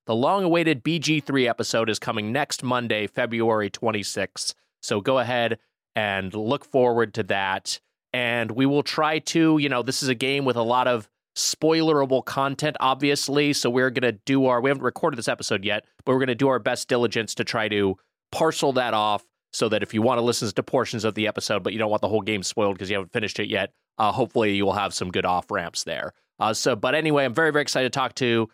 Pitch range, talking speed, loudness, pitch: 110-140 Hz, 225 wpm, -23 LUFS, 125 Hz